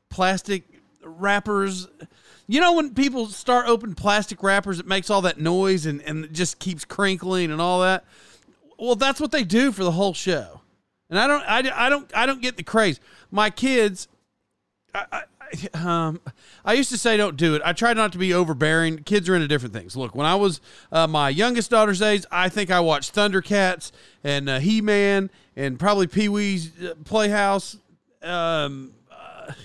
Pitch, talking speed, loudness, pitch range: 190 Hz, 180 wpm, -22 LUFS, 165-215 Hz